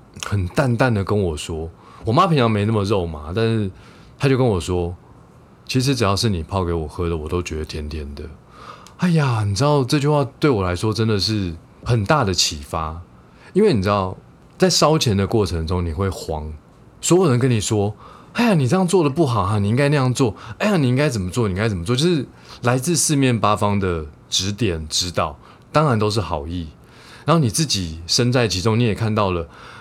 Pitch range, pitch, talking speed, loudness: 85-130 Hz, 105 Hz, 295 characters per minute, -19 LUFS